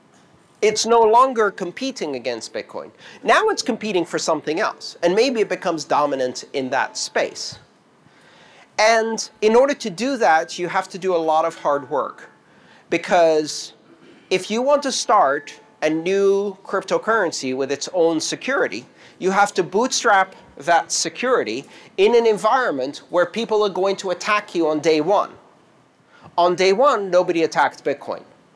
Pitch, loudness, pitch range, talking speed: 190 Hz, -19 LUFS, 165-220 Hz, 155 wpm